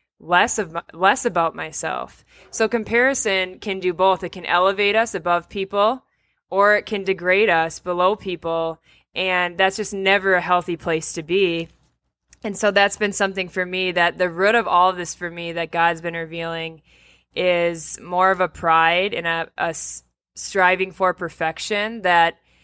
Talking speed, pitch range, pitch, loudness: 170 wpm, 170-195 Hz, 180 Hz, -20 LUFS